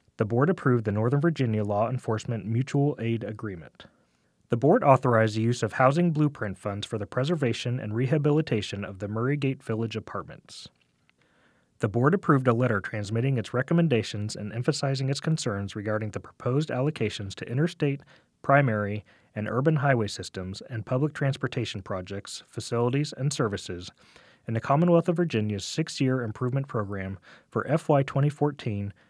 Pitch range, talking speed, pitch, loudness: 105-140 Hz, 150 wpm, 120 Hz, -27 LUFS